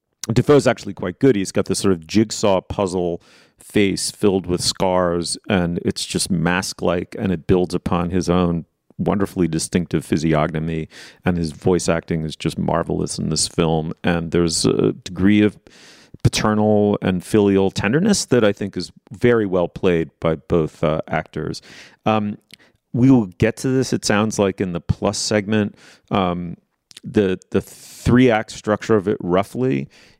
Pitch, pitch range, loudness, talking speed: 95 Hz, 85-105 Hz, -19 LUFS, 160 wpm